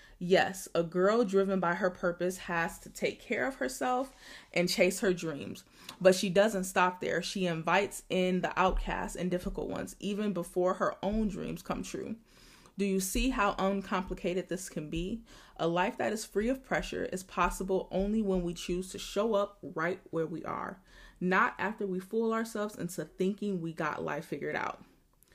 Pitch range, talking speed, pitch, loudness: 175-200 Hz, 180 wpm, 185 Hz, -32 LUFS